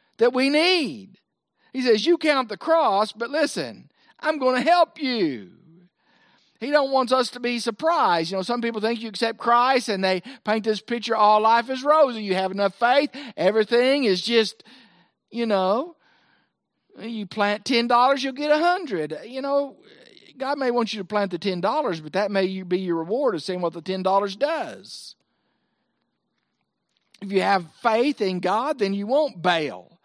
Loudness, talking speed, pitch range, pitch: -22 LUFS, 180 wpm, 195-270 Hz, 230 Hz